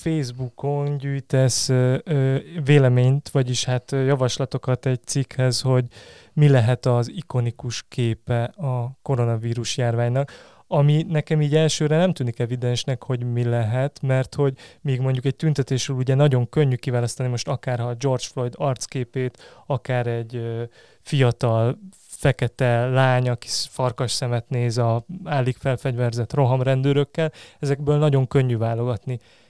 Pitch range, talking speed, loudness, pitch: 120-140 Hz, 120 wpm, -22 LUFS, 130 Hz